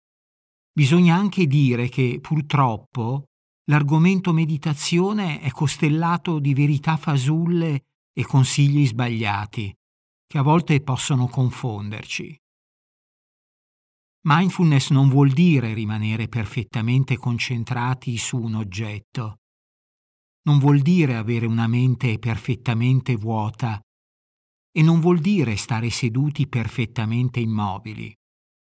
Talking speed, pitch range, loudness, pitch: 95 wpm, 115-150 Hz, -21 LUFS, 130 Hz